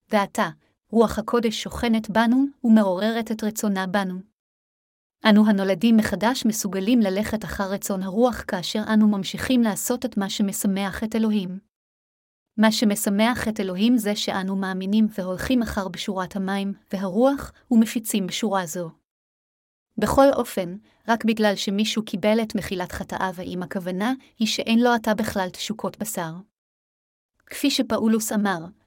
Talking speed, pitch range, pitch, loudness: 130 wpm, 195-225 Hz, 210 Hz, -23 LUFS